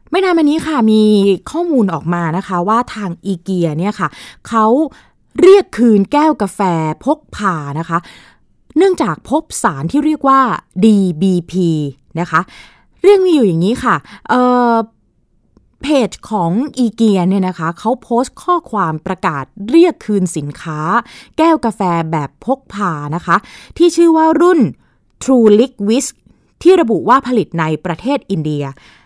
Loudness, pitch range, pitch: -14 LUFS, 175-275 Hz, 215 Hz